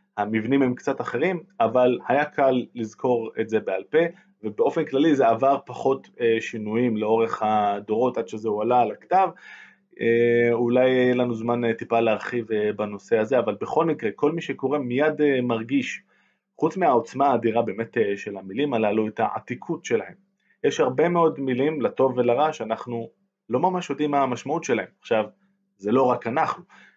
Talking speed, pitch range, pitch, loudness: 155 wpm, 115-145 Hz, 125 Hz, -23 LUFS